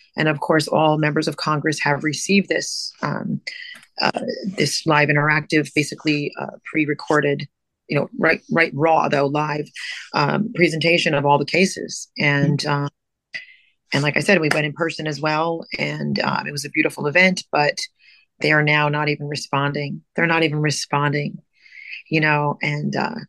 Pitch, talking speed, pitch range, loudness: 150 Hz, 165 wpm, 145-165 Hz, -20 LUFS